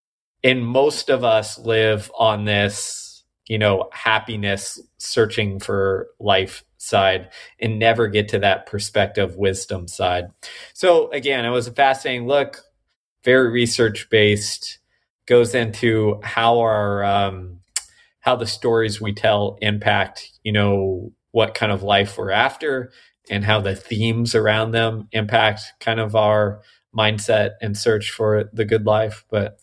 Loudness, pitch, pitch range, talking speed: -19 LUFS, 110 Hz, 100-115 Hz, 140 wpm